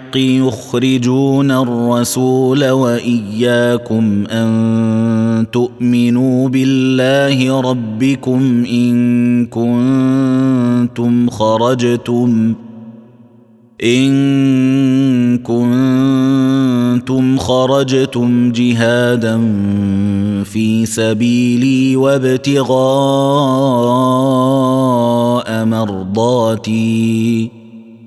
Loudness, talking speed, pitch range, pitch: -13 LUFS, 40 wpm, 115-130 Hz, 120 Hz